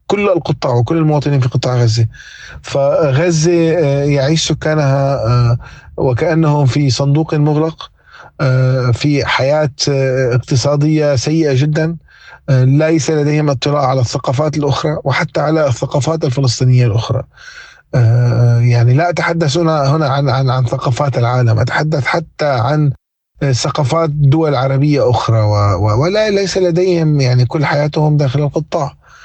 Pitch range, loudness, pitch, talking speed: 130-155 Hz, -13 LUFS, 145 Hz, 110 wpm